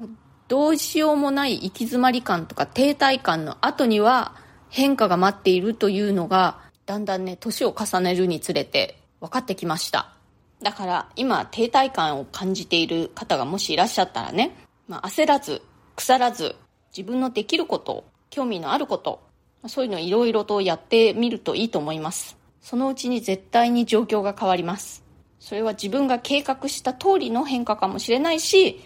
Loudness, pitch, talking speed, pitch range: -22 LUFS, 230 Hz, 350 characters per minute, 190-265 Hz